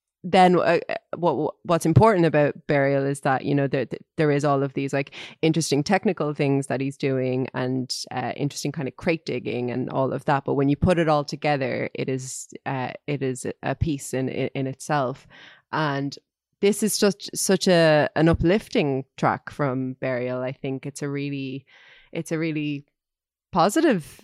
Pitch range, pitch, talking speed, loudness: 135-160 Hz, 145 Hz, 180 wpm, -23 LUFS